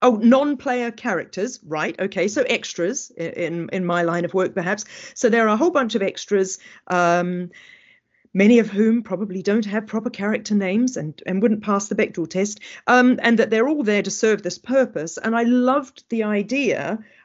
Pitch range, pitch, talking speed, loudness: 190-240 Hz, 215 Hz, 190 wpm, -21 LUFS